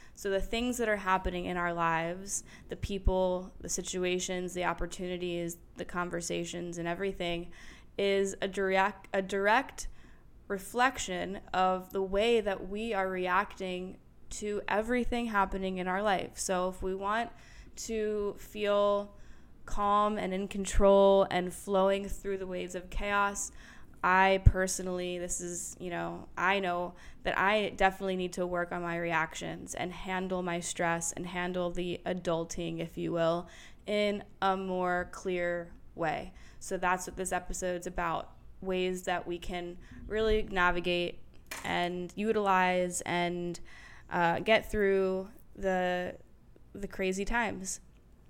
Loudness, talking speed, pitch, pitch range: -32 LUFS, 135 wpm, 185 Hz, 175-195 Hz